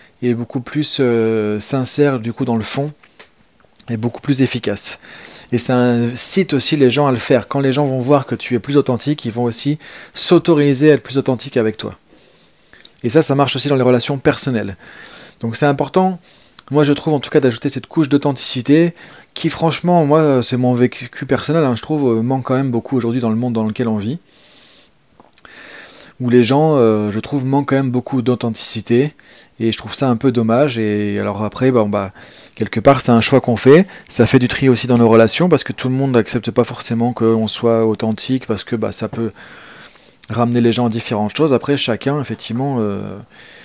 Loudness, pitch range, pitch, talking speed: -15 LUFS, 115-140 Hz, 125 Hz, 210 wpm